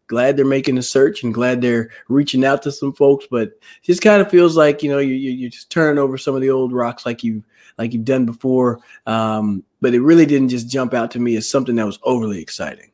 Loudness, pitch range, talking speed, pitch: -17 LUFS, 115-140 Hz, 255 wpm, 130 Hz